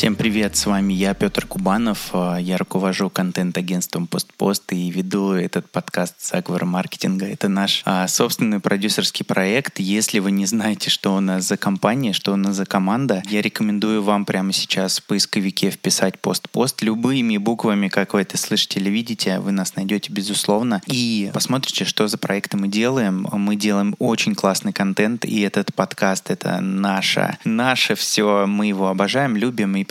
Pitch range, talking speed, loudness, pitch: 95-105 Hz, 165 wpm, -20 LUFS, 100 Hz